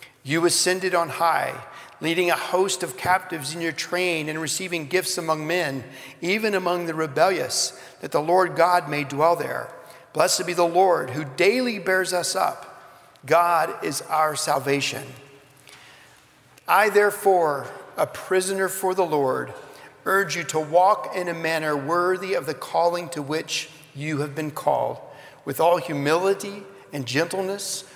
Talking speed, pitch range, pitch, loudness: 150 wpm, 155-185 Hz, 170 Hz, -23 LUFS